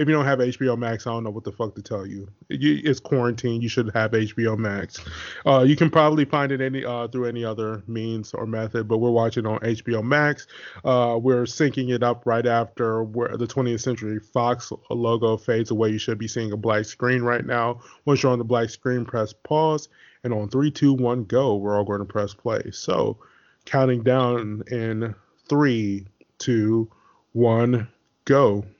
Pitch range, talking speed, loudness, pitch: 110-125 Hz, 200 wpm, -23 LUFS, 115 Hz